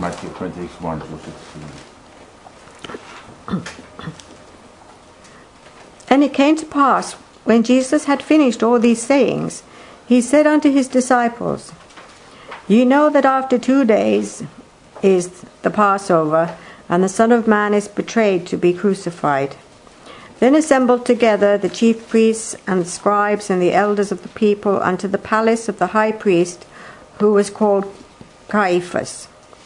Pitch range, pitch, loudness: 185-245 Hz, 210 Hz, -16 LUFS